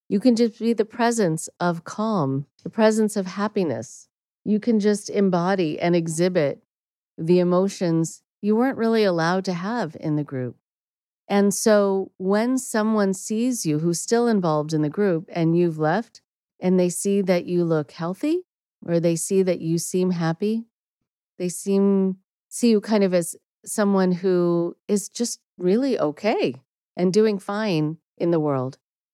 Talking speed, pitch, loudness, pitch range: 160 wpm, 185 Hz, -22 LUFS, 165-210 Hz